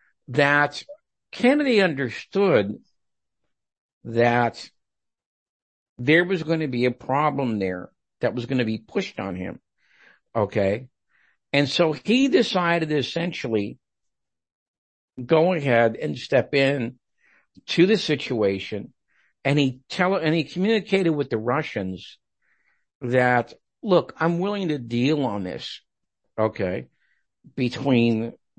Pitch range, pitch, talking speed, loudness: 115-165 Hz, 135 Hz, 110 wpm, -23 LUFS